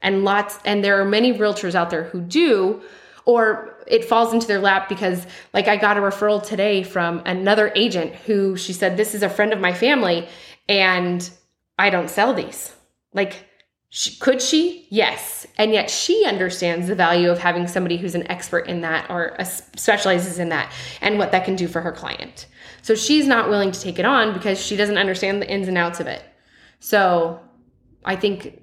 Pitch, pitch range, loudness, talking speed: 195 Hz, 180-215 Hz, -19 LUFS, 200 wpm